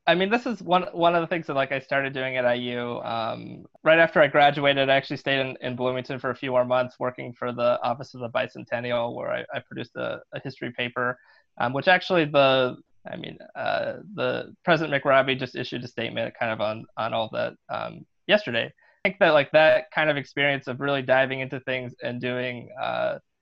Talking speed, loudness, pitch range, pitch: 220 wpm, -24 LUFS, 125-155 Hz, 135 Hz